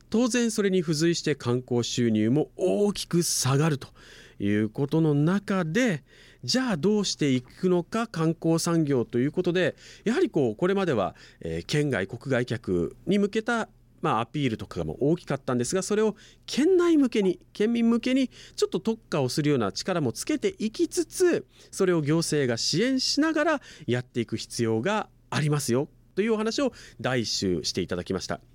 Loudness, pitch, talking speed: -26 LUFS, 165 Hz, 340 characters per minute